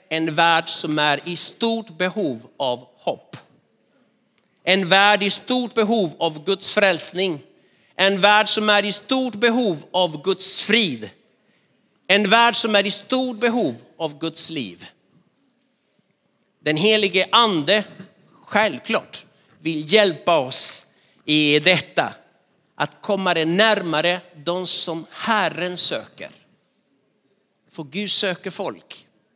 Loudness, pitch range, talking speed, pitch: -19 LUFS, 165-210 Hz, 120 wpm, 195 Hz